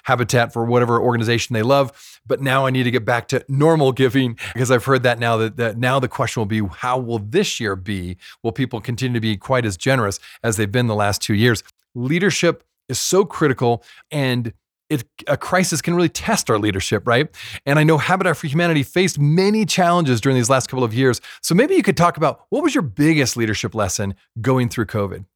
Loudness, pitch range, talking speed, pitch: -19 LUFS, 115-145 Hz, 220 wpm, 125 Hz